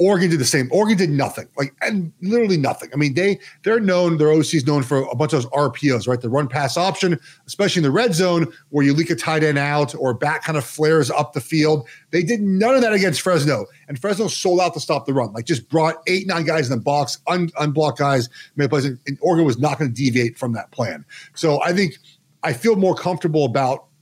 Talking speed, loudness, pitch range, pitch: 245 wpm, -19 LUFS, 140-175 Hz, 155 Hz